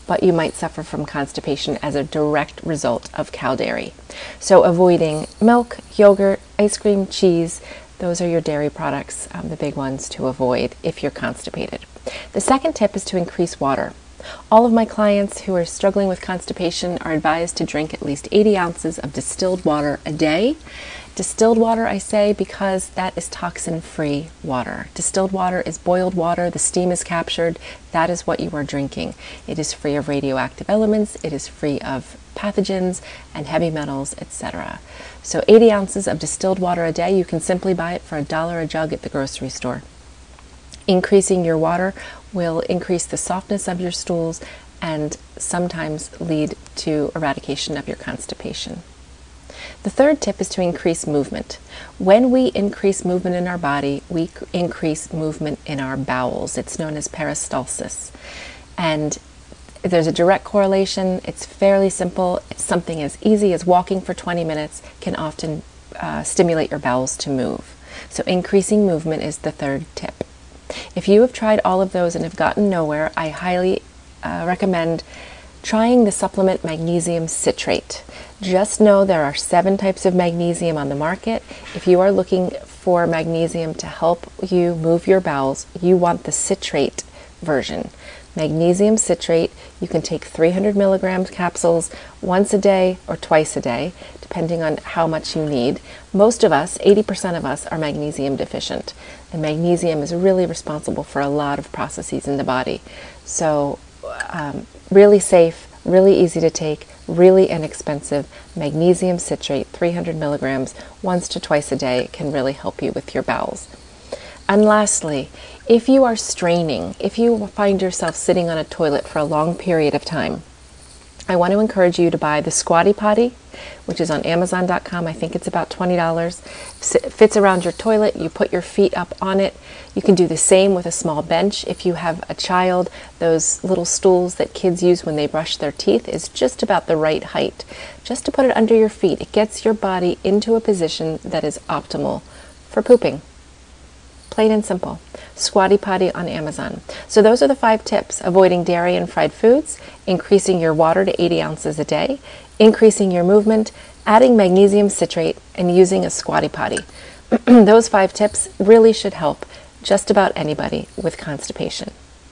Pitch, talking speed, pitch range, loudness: 175 Hz, 170 wpm, 155-195 Hz, -18 LUFS